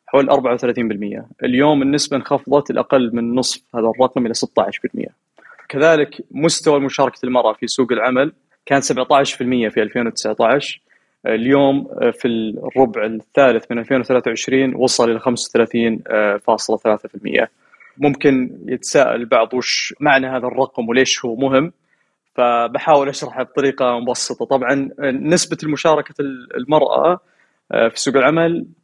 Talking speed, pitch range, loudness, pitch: 110 wpm, 120-140 Hz, -17 LUFS, 130 Hz